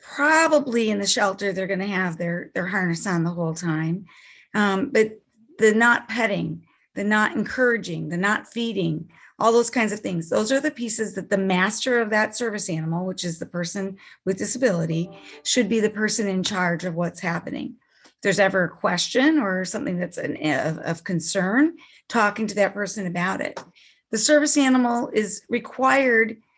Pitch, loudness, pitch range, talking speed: 205 Hz, -22 LUFS, 180-235 Hz, 180 wpm